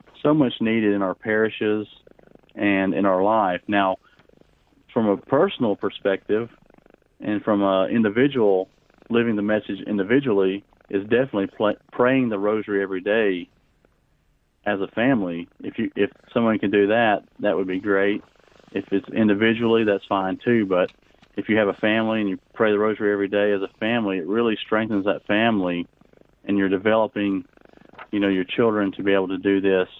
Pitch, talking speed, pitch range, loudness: 100 Hz, 170 wpm, 95-110 Hz, -22 LUFS